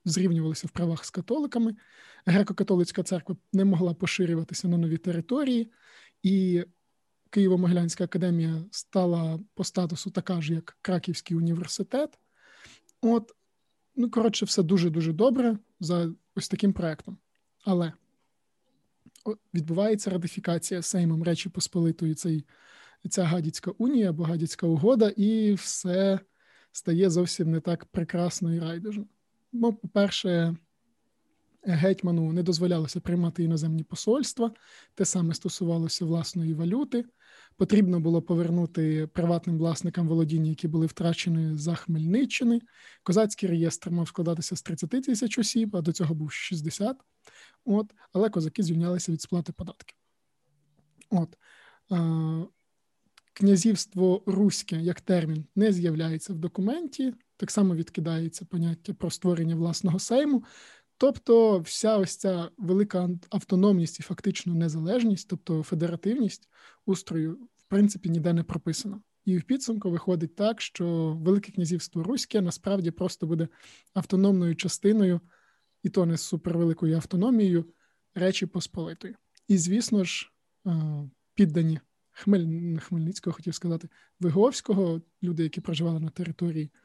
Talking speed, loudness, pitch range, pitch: 115 wpm, -27 LUFS, 170-200 Hz, 180 Hz